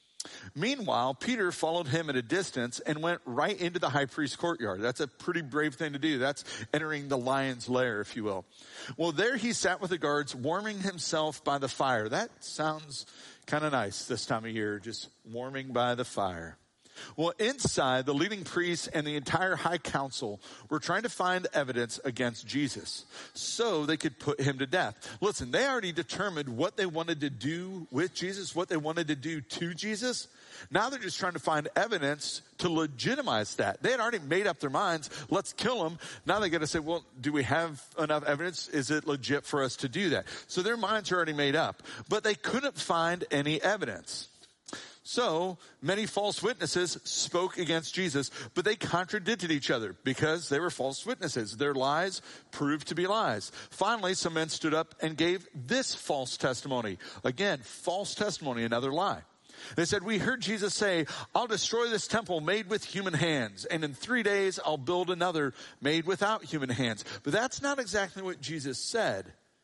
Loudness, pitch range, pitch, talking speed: -31 LUFS, 140-185 Hz, 160 Hz, 190 wpm